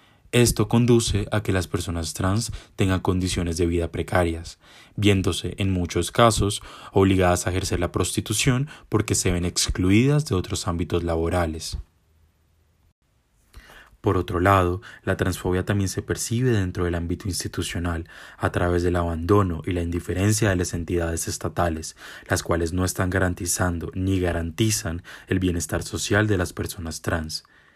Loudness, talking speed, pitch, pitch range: -23 LUFS, 145 wpm, 90 Hz, 85-100 Hz